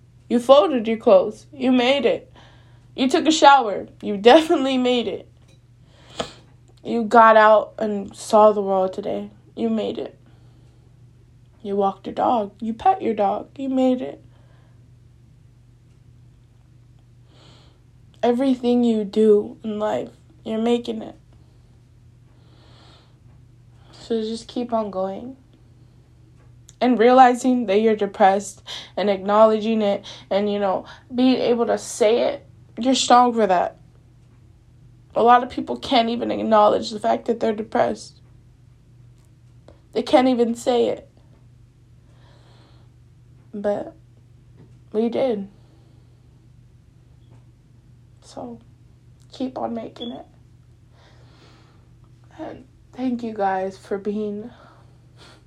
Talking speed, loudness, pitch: 110 wpm, -19 LUFS, 125 Hz